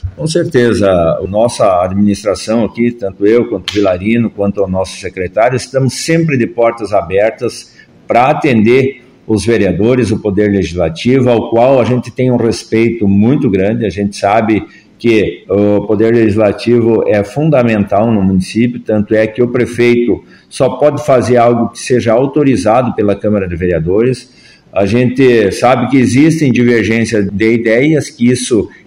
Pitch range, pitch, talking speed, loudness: 105-125 Hz, 115 Hz, 150 wpm, -11 LUFS